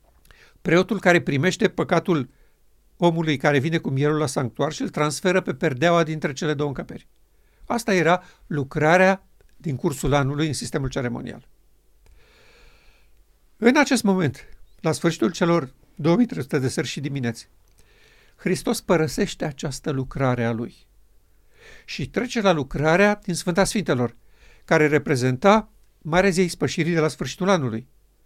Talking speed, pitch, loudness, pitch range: 130 wpm, 160 Hz, -22 LUFS, 140-185 Hz